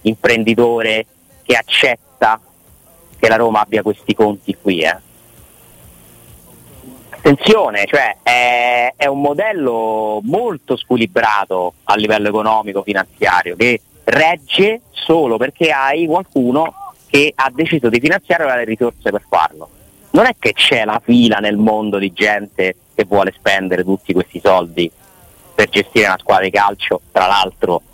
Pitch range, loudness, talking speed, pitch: 100-120 Hz, -14 LUFS, 135 wpm, 110 Hz